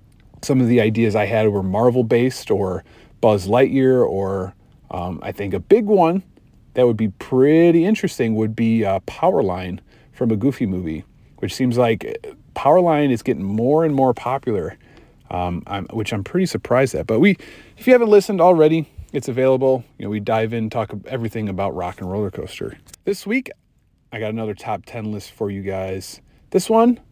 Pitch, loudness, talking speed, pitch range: 120 Hz, -19 LUFS, 185 wpm, 105-140 Hz